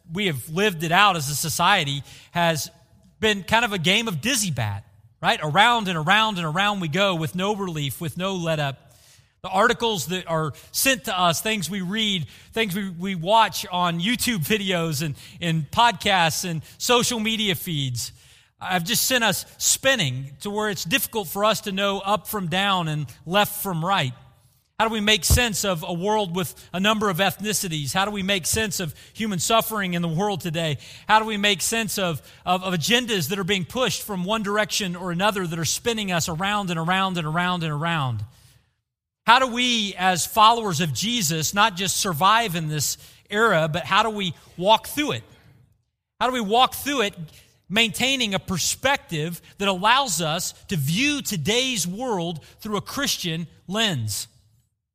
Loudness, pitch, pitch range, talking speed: -22 LUFS, 185 Hz, 155-215 Hz, 185 wpm